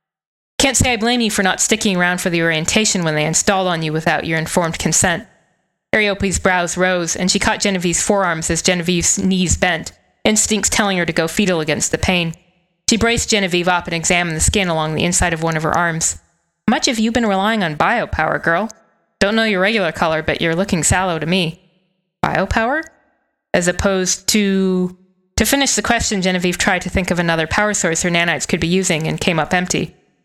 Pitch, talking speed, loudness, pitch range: 185 Hz, 200 wpm, -16 LUFS, 170-205 Hz